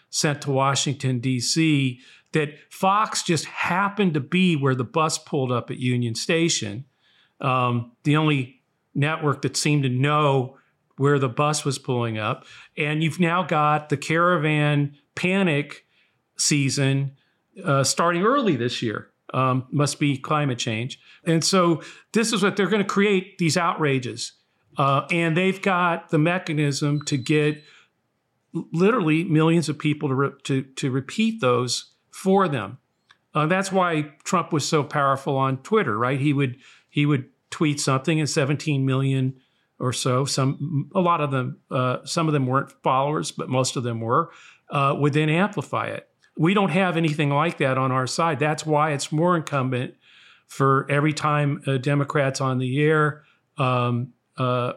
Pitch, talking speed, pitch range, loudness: 145 Hz, 160 wpm, 135-165 Hz, -22 LUFS